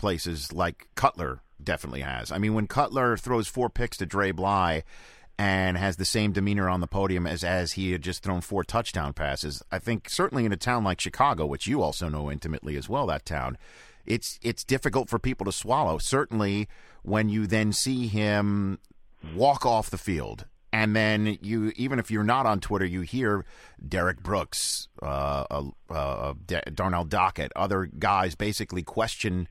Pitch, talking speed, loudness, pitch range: 100 Hz, 180 wpm, -27 LUFS, 90-110 Hz